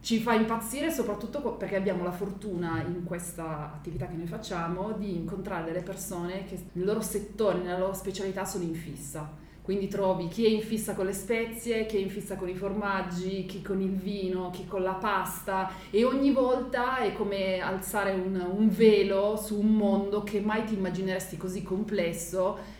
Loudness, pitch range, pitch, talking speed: -30 LUFS, 185-210 Hz, 195 Hz, 185 wpm